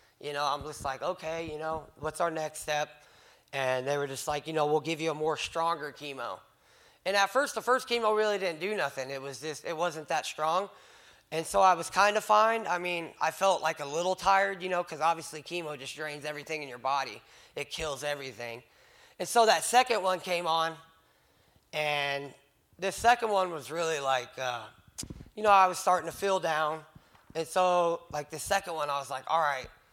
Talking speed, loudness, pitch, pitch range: 215 wpm, -30 LUFS, 160 Hz, 145-185 Hz